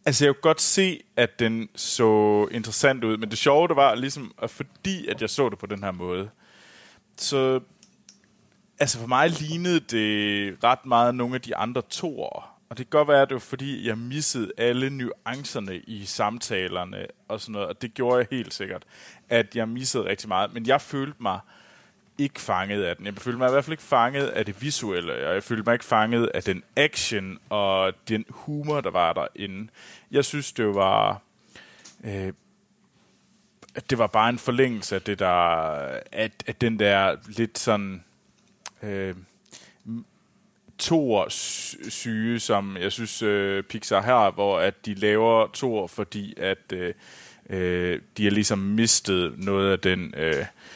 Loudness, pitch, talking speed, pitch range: -24 LUFS, 115 Hz, 175 wpm, 100-130 Hz